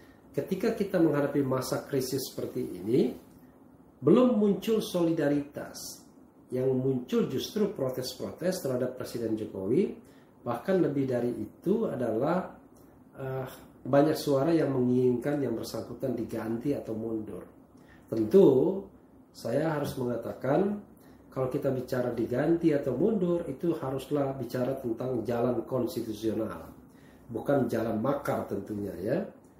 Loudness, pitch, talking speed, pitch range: -29 LUFS, 130 Hz, 105 wpm, 115-145 Hz